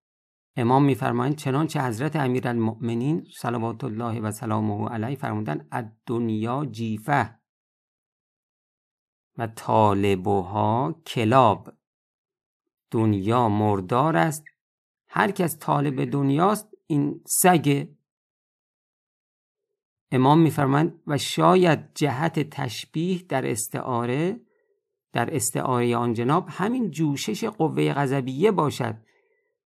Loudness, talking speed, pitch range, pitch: -24 LUFS, 90 wpm, 115-160 Hz, 135 Hz